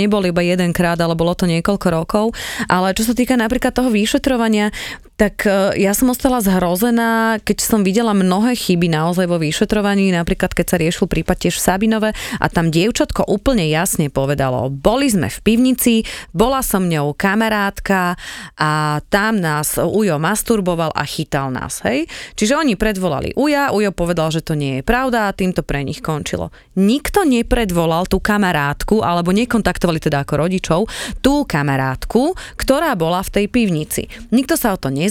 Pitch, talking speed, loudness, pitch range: 195 Hz, 165 wpm, -17 LUFS, 170-225 Hz